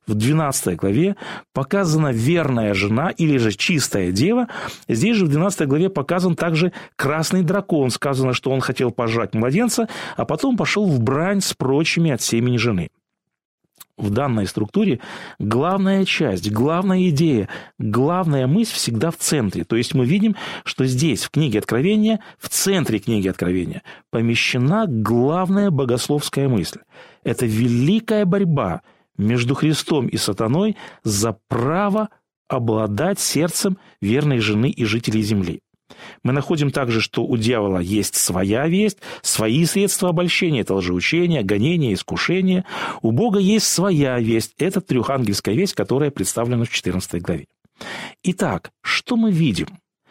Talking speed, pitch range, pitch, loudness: 135 wpm, 115-185 Hz, 140 Hz, -19 LUFS